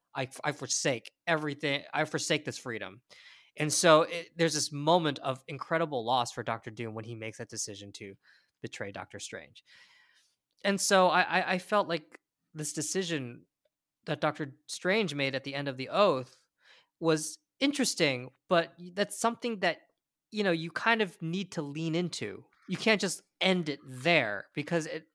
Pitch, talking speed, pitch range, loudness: 160 Hz, 165 wpm, 140-185 Hz, -30 LUFS